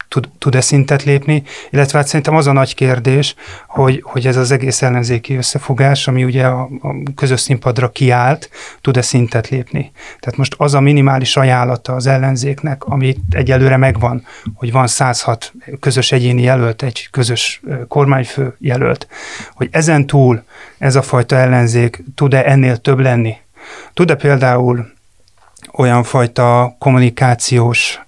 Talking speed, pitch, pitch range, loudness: 135 wpm, 130 Hz, 125-140 Hz, -13 LUFS